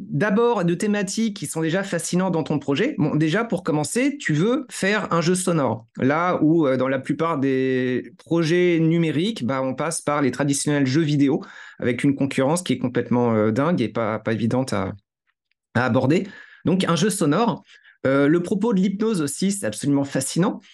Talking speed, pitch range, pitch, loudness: 190 wpm, 130-180 Hz, 155 Hz, -21 LUFS